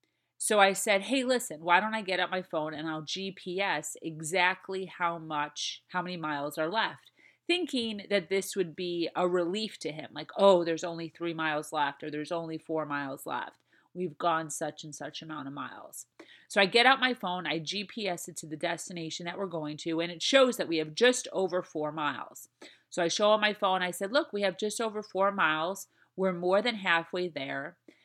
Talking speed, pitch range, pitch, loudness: 210 wpm, 160-195 Hz, 180 Hz, -30 LUFS